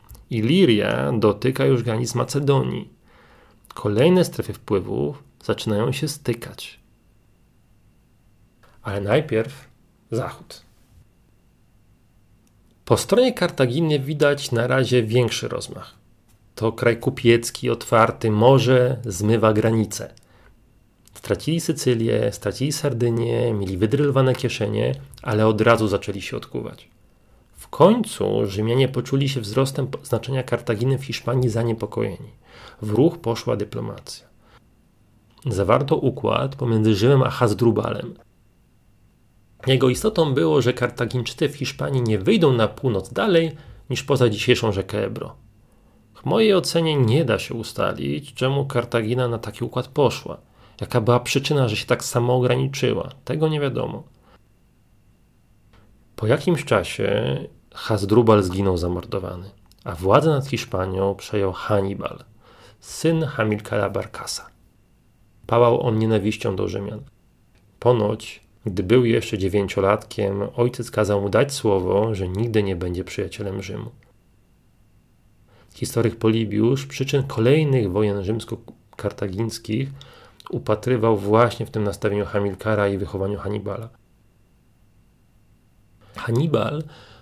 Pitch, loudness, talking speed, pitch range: 115 Hz, -21 LUFS, 105 wpm, 105-130 Hz